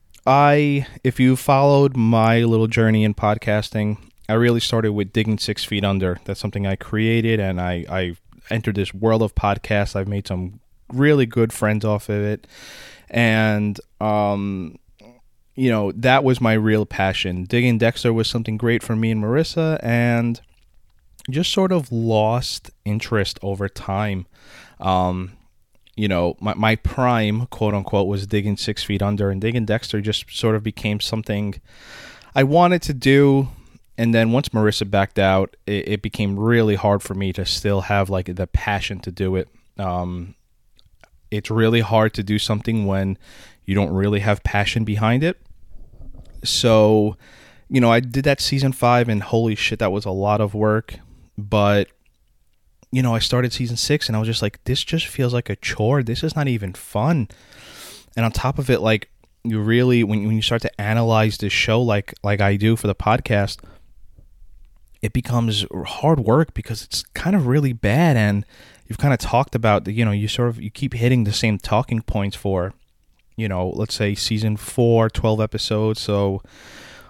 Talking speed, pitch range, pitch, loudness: 180 wpm, 100-120 Hz, 110 Hz, -20 LUFS